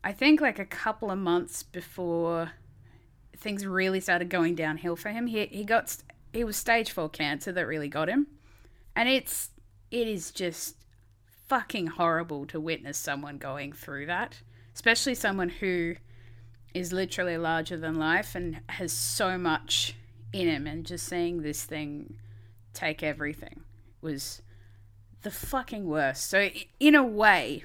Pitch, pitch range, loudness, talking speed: 160 Hz, 115-185 Hz, -29 LUFS, 150 wpm